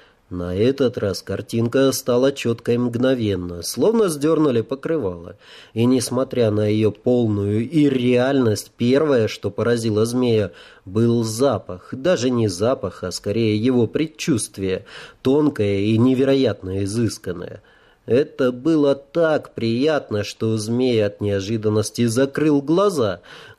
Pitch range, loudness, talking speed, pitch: 105-135 Hz, -20 LUFS, 110 wpm, 120 Hz